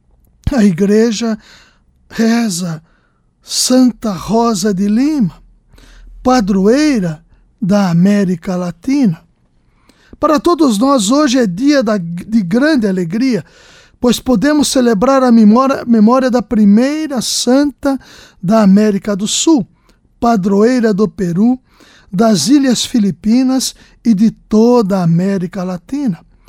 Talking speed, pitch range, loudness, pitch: 100 wpm, 195-255 Hz, -12 LUFS, 225 Hz